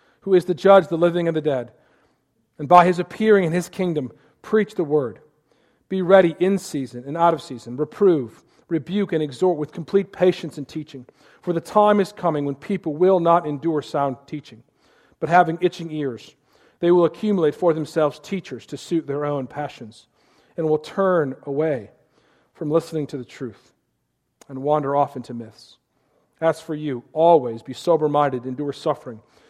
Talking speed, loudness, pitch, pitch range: 175 wpm, -21 LUFS, 155 Hz, 140-175 Hz